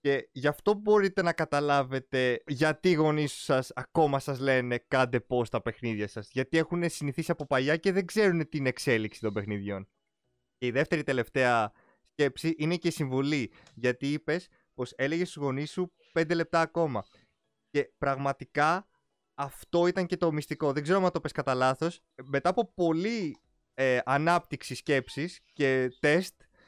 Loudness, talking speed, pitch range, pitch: -29 LUFS, 155 wpm, 130-165 Hz, 145 Hz